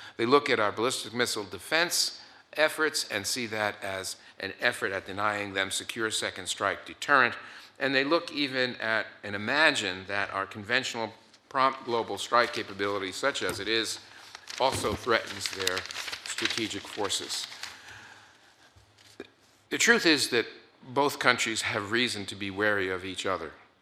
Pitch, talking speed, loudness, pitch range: 110 Hz, 145 wpm, -28 LUFS, 100-125 Hz